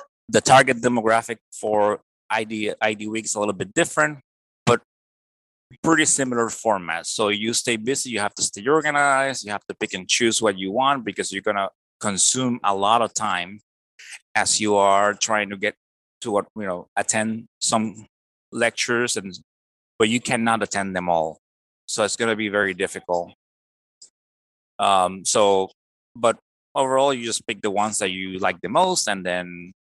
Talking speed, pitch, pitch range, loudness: 170 wpm, 105 Hz, 90-120 Hz, -21 LUFS